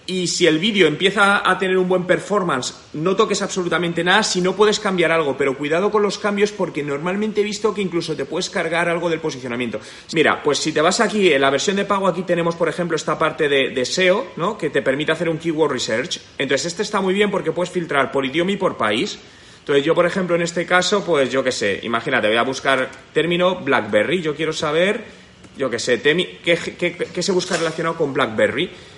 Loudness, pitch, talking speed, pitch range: -19 LUFS, 175 Hz, 230 wpm, 160-190 Hz